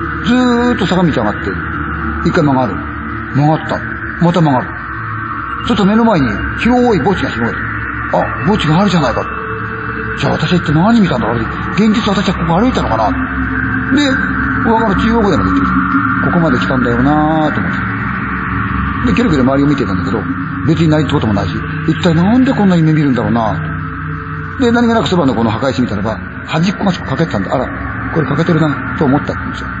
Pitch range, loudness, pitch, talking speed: 110-175 Hz, -13 LUFS, 140 Hz, 390 characters per minute